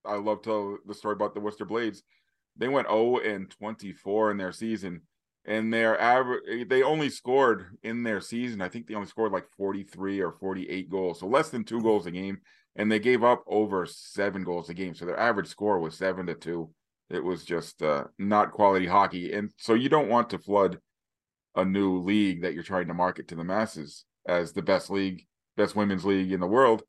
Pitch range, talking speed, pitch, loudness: 95-110 Hz, 215 wpm, 100 Hz, -28 LUFS